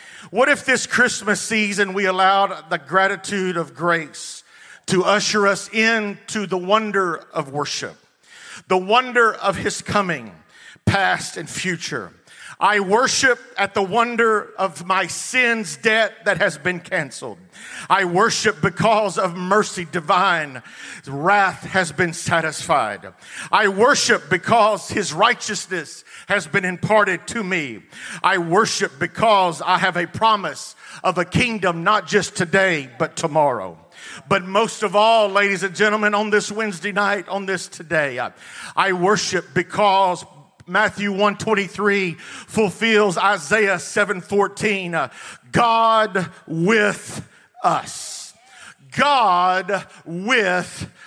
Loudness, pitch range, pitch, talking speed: -19 LUFS, 180-210 Hz, 195 Hz, 120 wpm